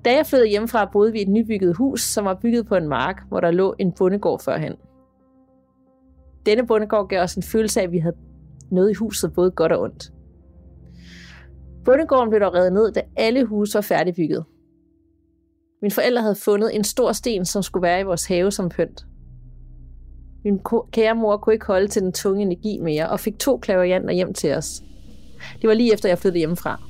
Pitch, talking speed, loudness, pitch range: 185 Hz, 200 wpm, -20 LUFS, 130-215 Hz